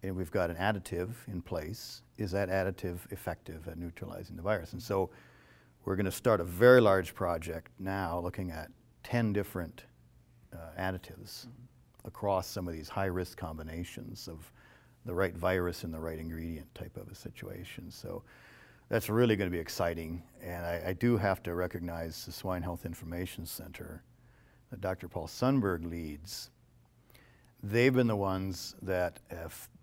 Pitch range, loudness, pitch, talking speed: 85-105 Hz, -33 LUFS, 95 Hz, 155 wpm